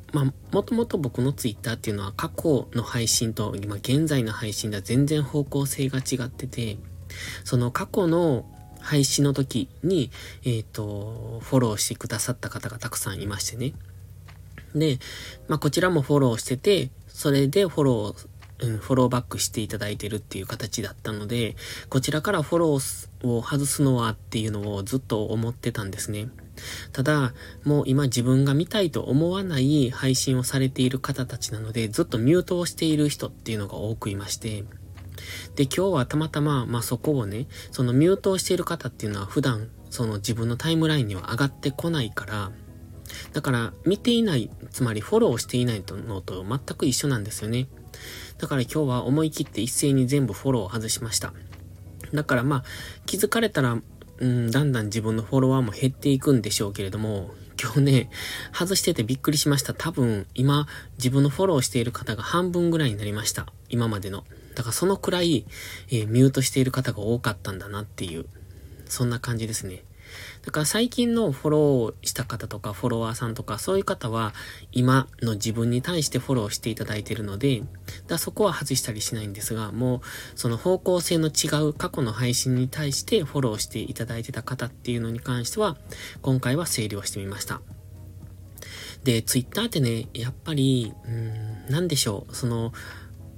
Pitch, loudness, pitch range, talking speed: 120 Hz, -25 LUFS, 105-140 Hz, 380 characters per minute